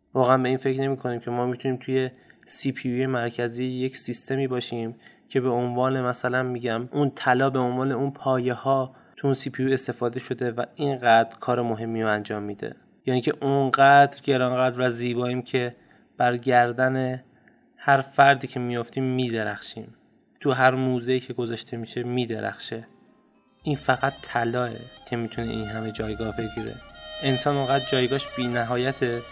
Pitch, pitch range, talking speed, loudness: 125 Hz, 120-130 Hz, 155 wpm, -25 LUFS